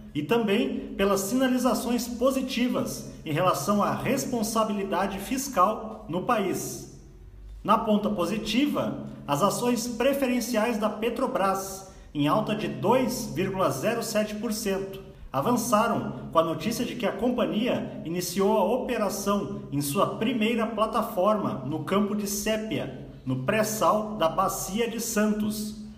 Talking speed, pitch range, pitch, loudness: 115 wpm, 195-235 Hz, 215 Hz, -26 LUFS